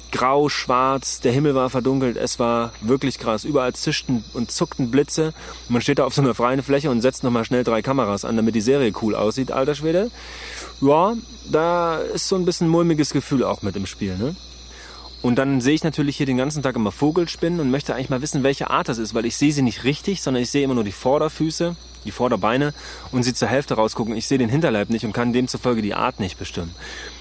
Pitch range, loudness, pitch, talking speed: 115-145 Hz, -21 LUFS, 130 Hz, 225 wpm